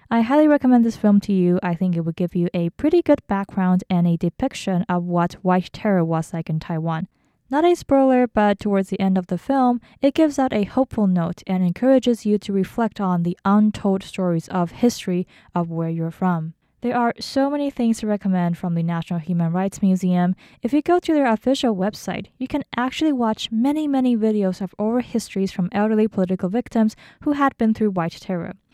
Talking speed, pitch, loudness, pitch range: 205 wpm, 200 Hz, -21 LUFS, 180-245 Hz